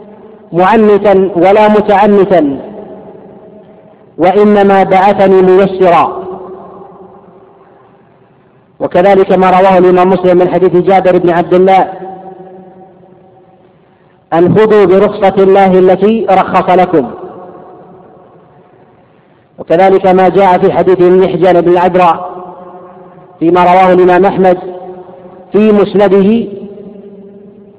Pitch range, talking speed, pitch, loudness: 180-200 Hz, 80 wpm, 185 Hz, -7 LUFS